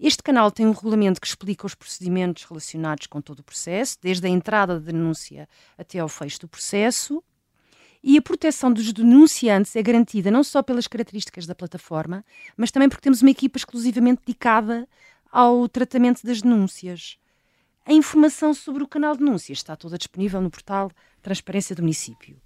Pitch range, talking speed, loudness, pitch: 180-255 Hz, 175 wpm, -20 LUFS, 210 Hz